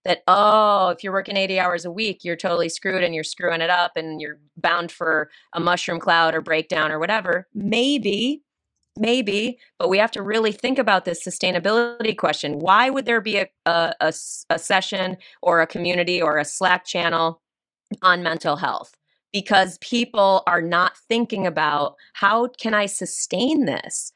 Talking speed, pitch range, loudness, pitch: 175 wpm, 170-215 Hz, -21 LUFS, 185 Hz